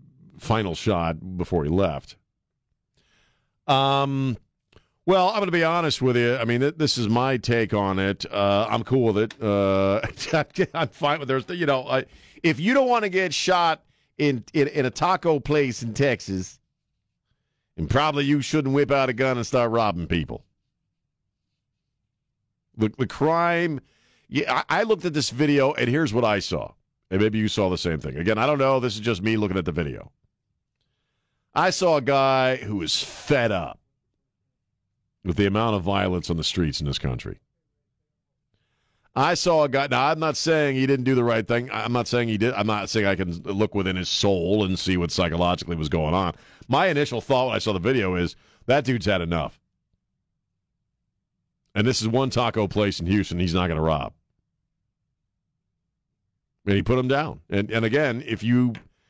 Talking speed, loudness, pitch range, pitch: 190 wpm, -23 LUFS, 100-140 Hz, 120 Hz